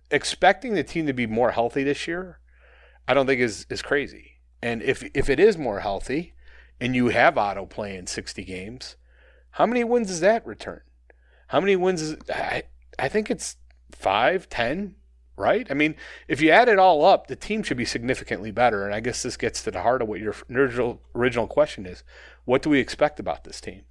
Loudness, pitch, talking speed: -23 LUFS, 120 Hz, 210 wpm